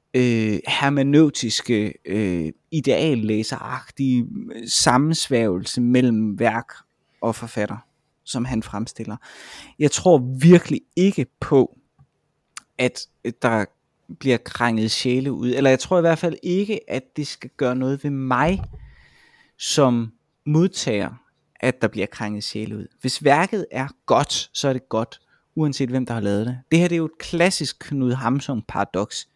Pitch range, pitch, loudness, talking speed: 110-150 Hz, 130 Hz, -21 LUFS, 140 wpm